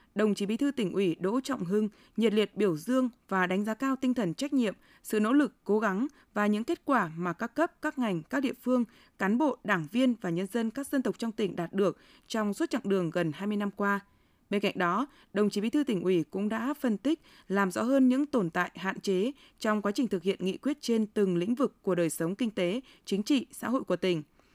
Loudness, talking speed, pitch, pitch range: -30 LUFS, 250 wpm, 215 Hz, 195-255 Hz